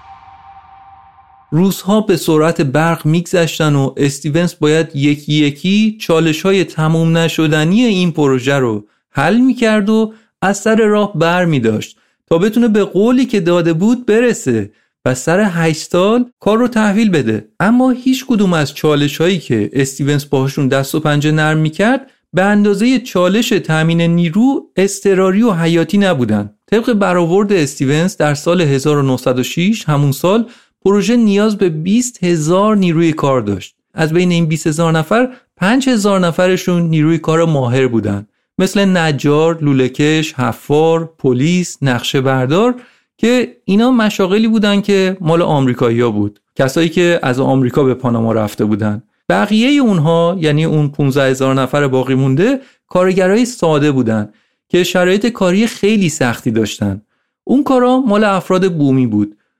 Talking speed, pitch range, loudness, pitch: 140 wpm, 140-205 Hz, -13 LUFS, 165 Hz